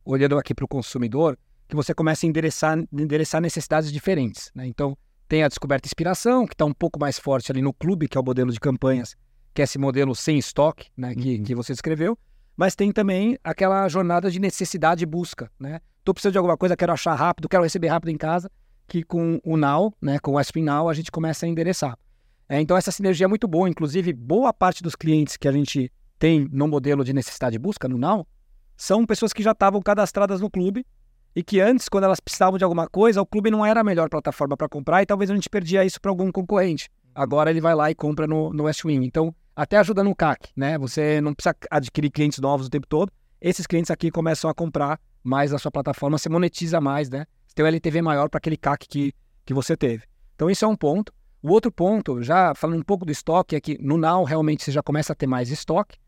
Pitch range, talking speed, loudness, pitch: 140-185 Hz, 235 wpm, -22 LUFS, 155 Hz